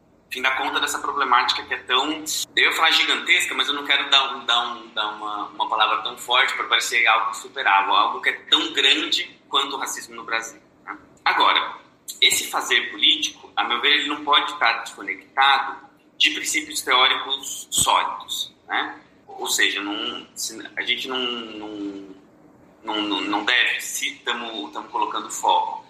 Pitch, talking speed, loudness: 145 Hz, 165 wpm, -20 LUFS